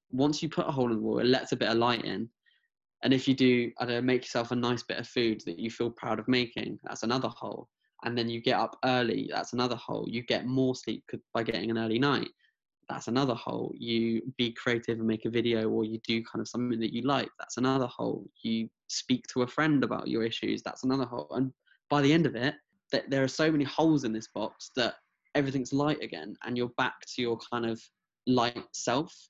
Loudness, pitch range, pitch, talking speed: -30 LUFS, 115-130 Hz, 120 Hz, 235 wpm